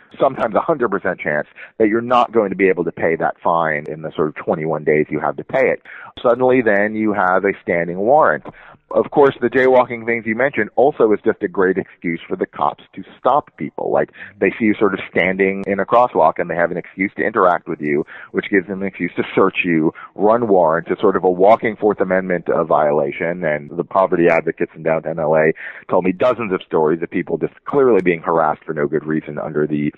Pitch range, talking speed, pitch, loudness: 90-115 Hz, 230 wpm, 100 Hz, -17 LUFS